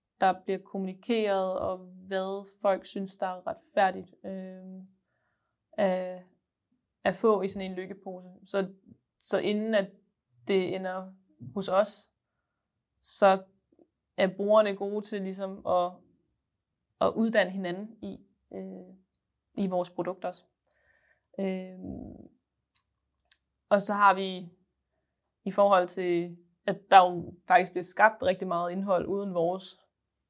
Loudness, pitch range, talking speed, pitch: -28 LUFS, 185-200 Hz, 120 wpm, 190 Hz